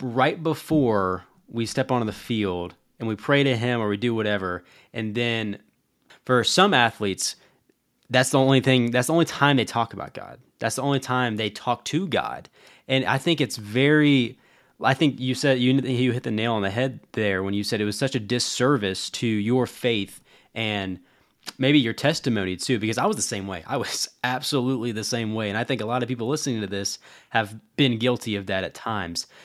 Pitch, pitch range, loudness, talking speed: 120 Hz, 105-130 Hz, -24 LUFS, 210 wpm